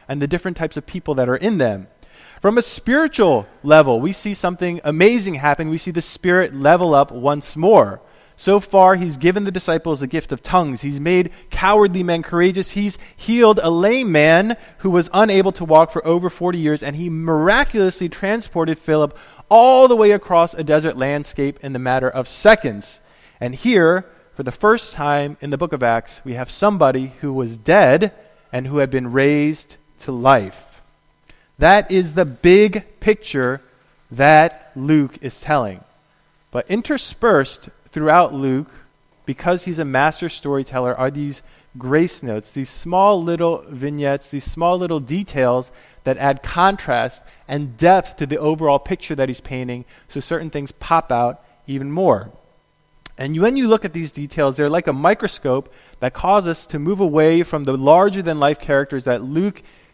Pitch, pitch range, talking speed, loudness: 160 Hz, 140-185 Hz, 170 wpm, -17 LUFS